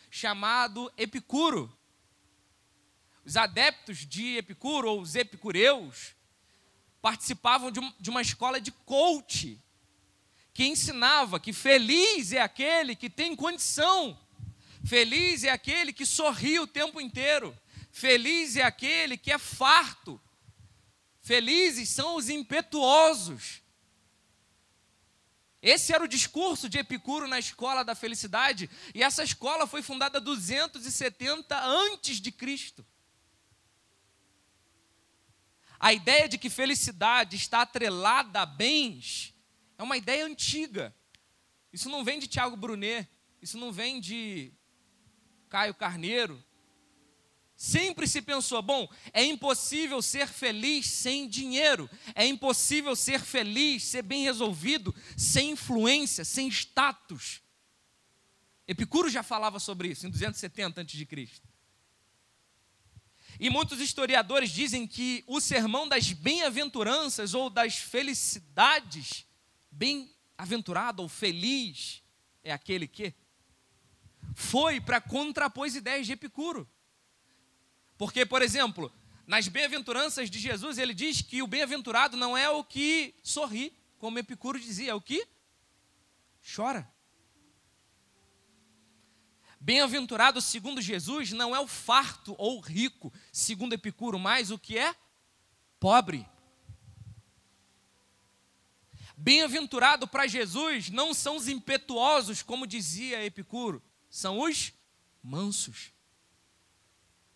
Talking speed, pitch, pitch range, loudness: 110 wpm, 245 Hz, 190-275 Hz, -28 LUFS